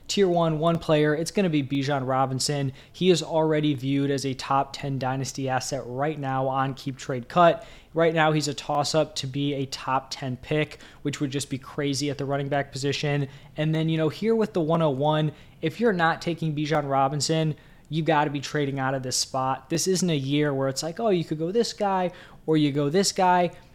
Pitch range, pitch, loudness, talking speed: 135-160 Hz, 150 Hz, -25 LUFS, 225 wpm